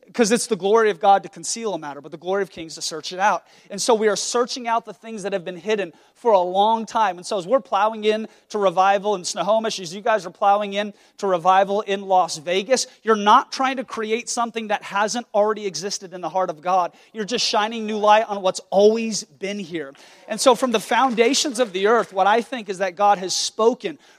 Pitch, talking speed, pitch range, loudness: 210 Hz, 240 wpm, 190-225 Hz, -21 LUFS